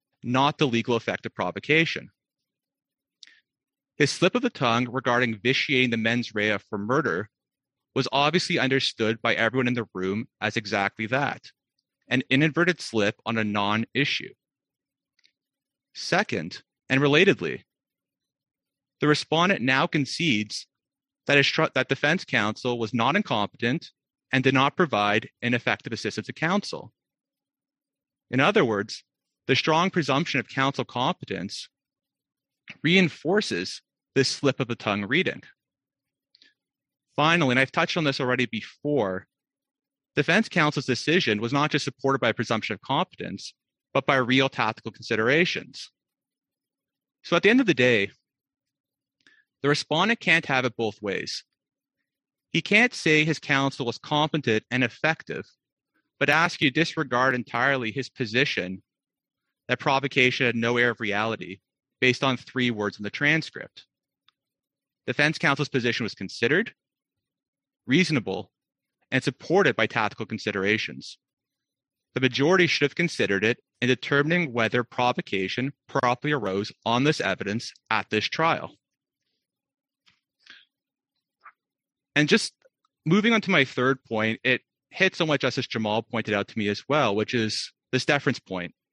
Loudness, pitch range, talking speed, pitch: -24 LUFS, 110-145 Hz, 135 wpm, 130 Hz